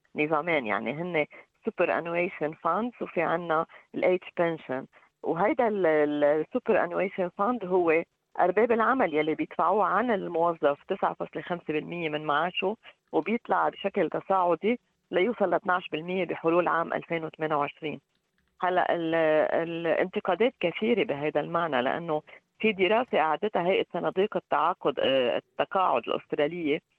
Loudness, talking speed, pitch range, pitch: -27 LUFS, 105 wpm, 155-190 Hz, 170 Hz